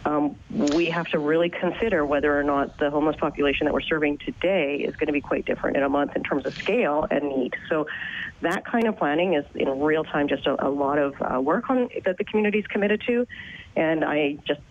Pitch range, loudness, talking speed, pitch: 145-180 Hz, -24 LUFS, 235 wpm, 150 Hz